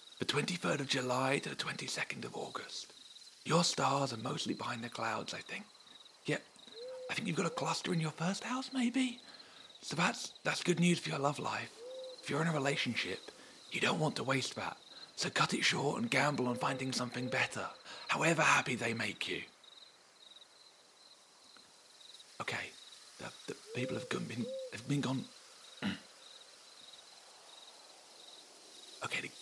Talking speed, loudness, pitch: 155 wpm, -36 LUFS, 150 Hz